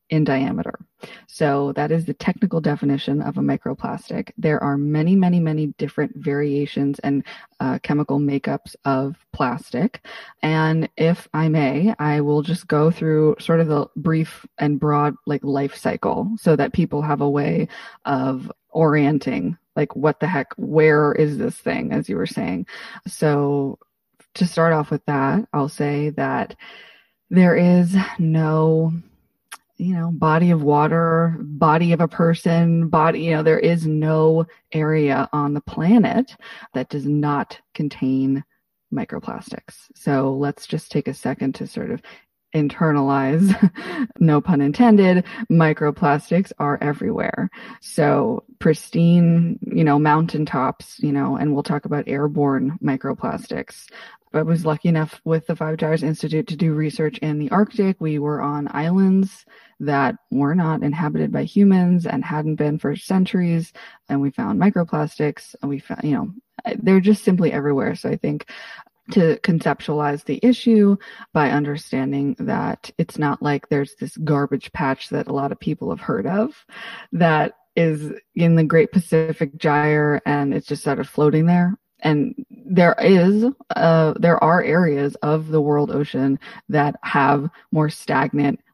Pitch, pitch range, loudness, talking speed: 160 Hz, 145-200 Hz, -20 LUFS, 150 wpm